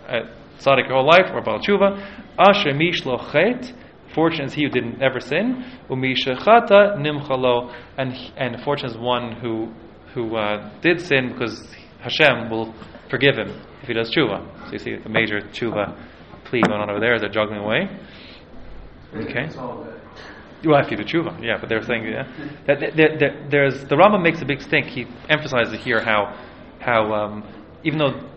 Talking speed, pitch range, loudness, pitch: 180 wpm, 110-145 Hz, -20 LUFS, 125 Hz